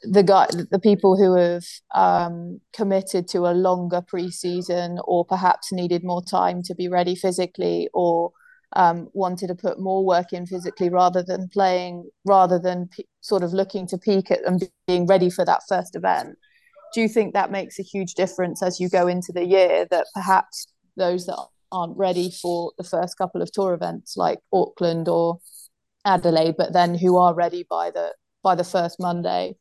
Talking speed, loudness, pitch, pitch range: 185 wpm, -22 LUFS, 180 Hz, 175-190 Hz